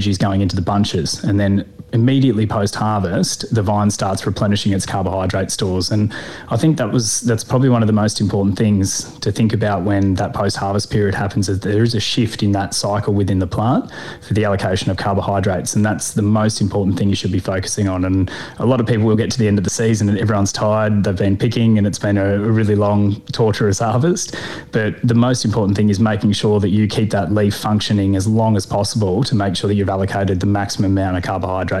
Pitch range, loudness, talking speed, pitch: 100-110 Hz, -17 LUFS, 225 wpm, 105 Hz